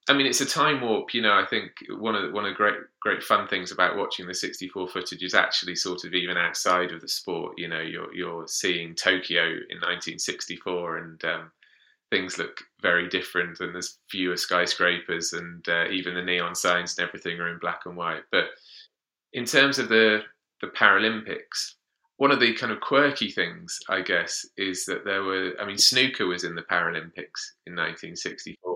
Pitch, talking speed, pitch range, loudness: 90 Hz, 195 wpm, 85-105 Hz, -25 LUFS